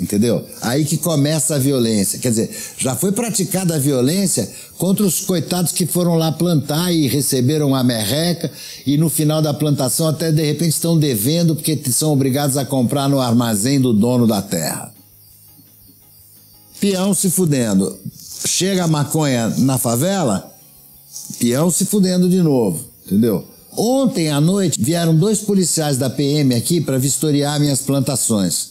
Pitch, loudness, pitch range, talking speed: 145 Hz, -17 LUFS, 125-170 Hz, 150 wpm